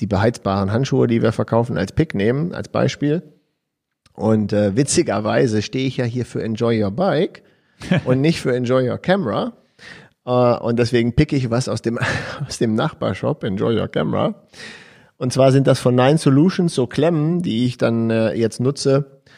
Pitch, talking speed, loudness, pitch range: 125 Hz, 175 wpm, -19 LUFS, 115-140 Hz